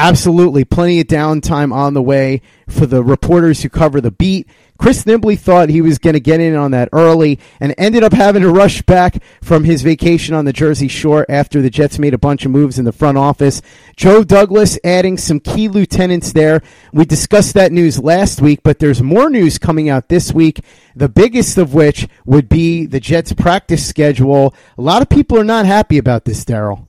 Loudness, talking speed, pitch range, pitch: -11 LUFS, 210 wpm, 140-175 Hz, 155 Hz